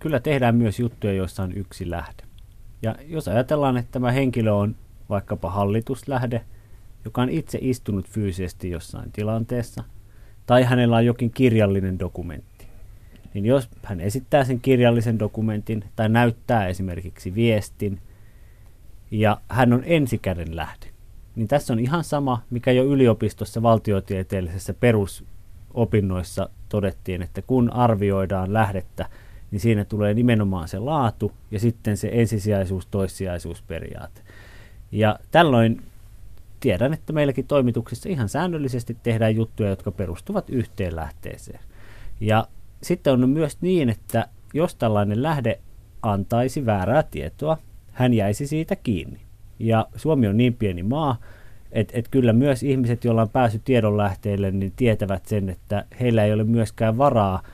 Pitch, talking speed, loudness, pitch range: 110 Hz, 130 wpm, -22 LUFS, 100-120 Hz